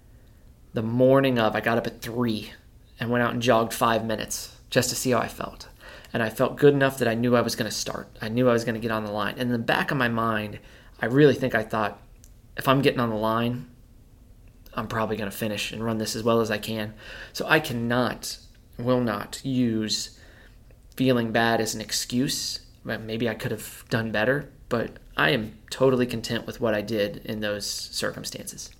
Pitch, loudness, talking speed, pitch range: 115 Hz, -25 LUFS, 215 wpm, 110-125 Hz